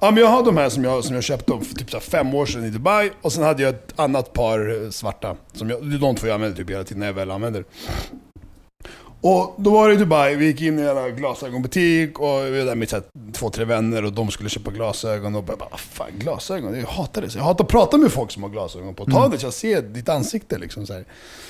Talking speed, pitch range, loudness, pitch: 255 wpm, 110-155 Hz, -20 LUFS, 125 Hz